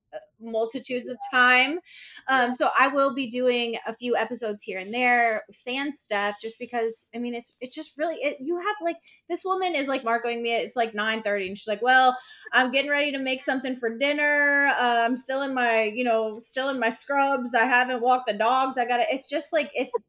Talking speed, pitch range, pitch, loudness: 220 wpm, 230-275 Hz, 250 Hz, -24 LUFS